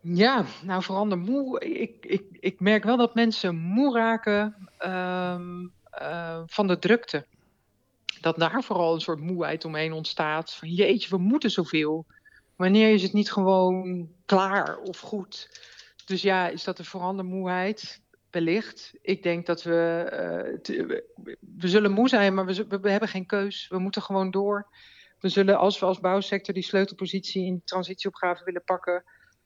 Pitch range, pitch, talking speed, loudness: 180-205 Hz, 190 Hz, 170 wpm, -26 LUFS